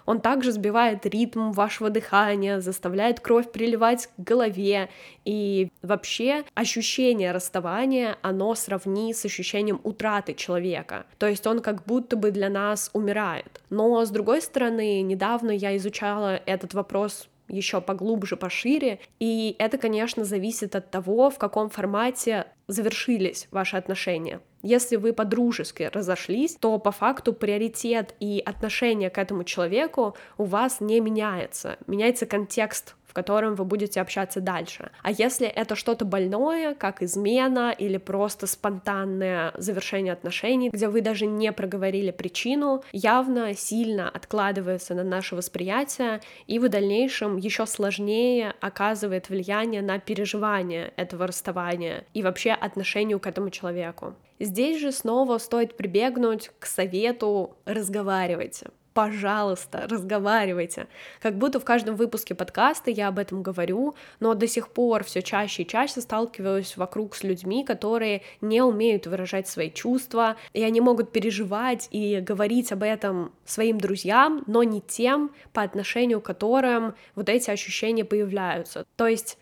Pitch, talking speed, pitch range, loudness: 210 Hz, 135 wpm, 195-230 Hz, -25 LUFS